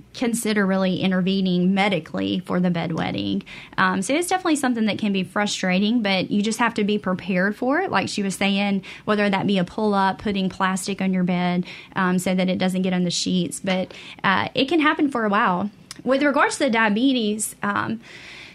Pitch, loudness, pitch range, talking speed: 195 Hz, -22 LUFS, 185-215 Hz, 200 wpm